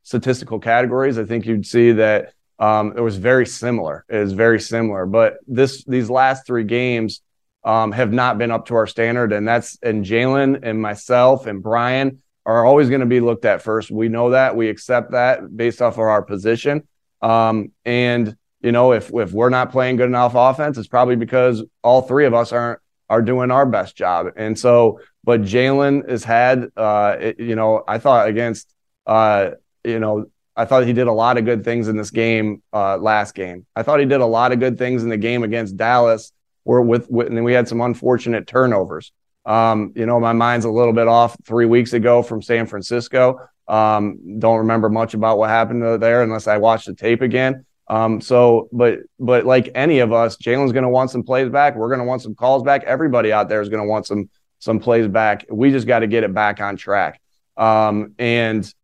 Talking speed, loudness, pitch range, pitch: 215 wpm, -17 LUFS, 110-125 Hz, 115 Hz